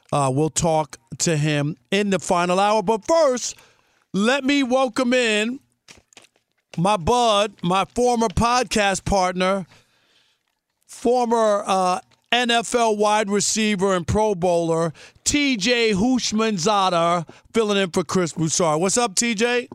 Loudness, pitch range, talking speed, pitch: -20 LUFS, 180-235 Hz, 120 wpm, 205 Hz